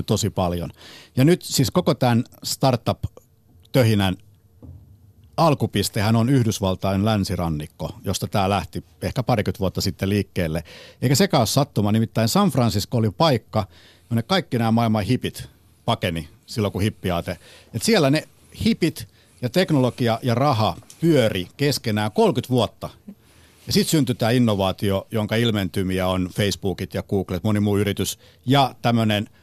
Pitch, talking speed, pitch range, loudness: 110 Hz, 135 wpm, 95-125 Hz, -22 LUFS